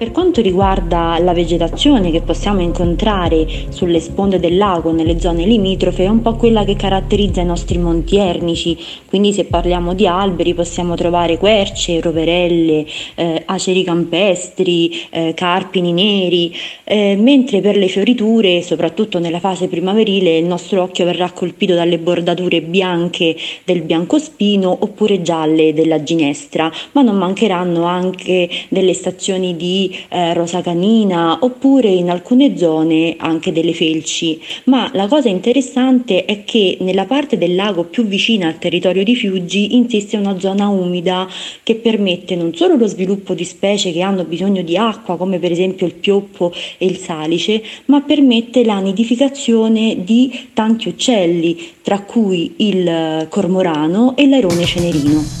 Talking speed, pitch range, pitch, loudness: 145 wpm, 170-205 Hz, 185 Hz, -14 LUFS